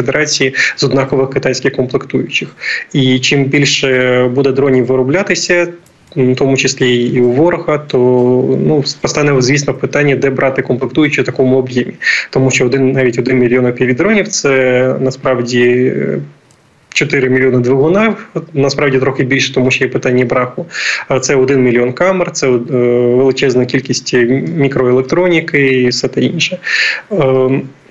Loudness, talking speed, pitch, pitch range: -12 LUFS, 135 wpm, 130 Hz, 125-140 Hz